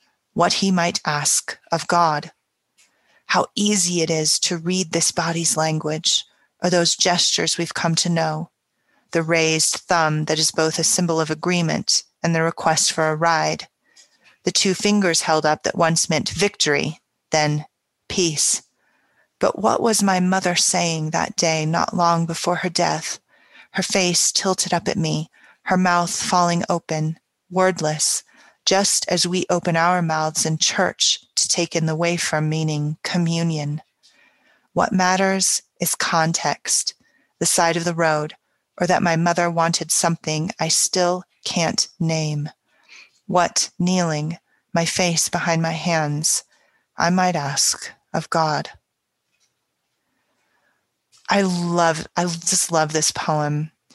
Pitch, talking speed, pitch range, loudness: 170 Hz, 140 wpm, 160-180 Hz, -20 LUFS